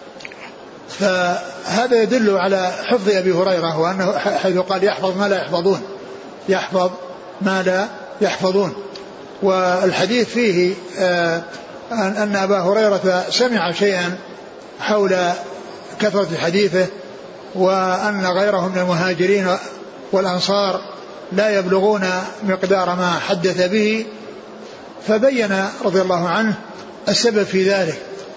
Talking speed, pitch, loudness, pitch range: 95 wpm, 190 Hz, -18 LUFS, 185-200 Hz